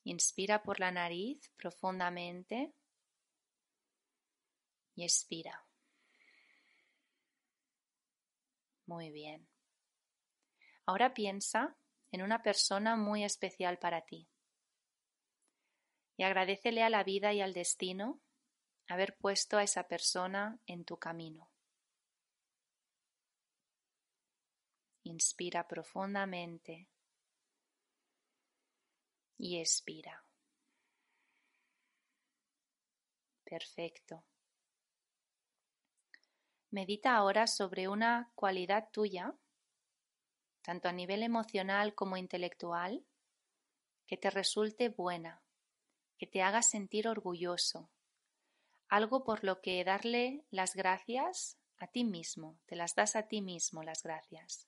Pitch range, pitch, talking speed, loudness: 180-235 Hz, 200 Hz, 85 wpm, -36 LUFS